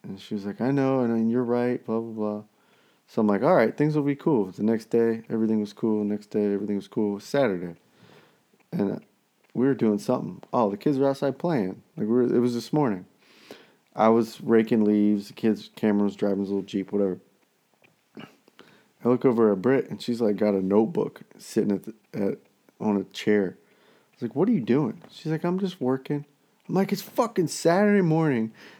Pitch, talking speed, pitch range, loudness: 115 Hz, 220 wpm, 105-135 Hz, -25 LUFS